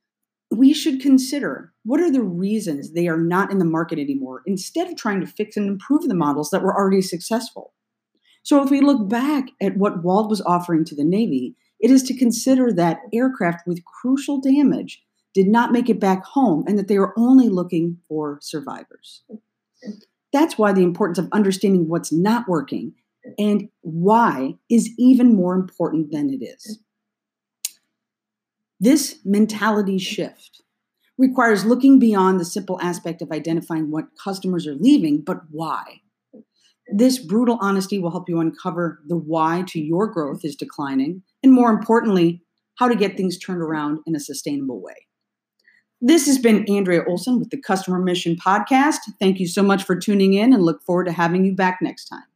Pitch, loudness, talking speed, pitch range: 200 Hz, -19 LUFS, 175 wpm, 175-245 Hz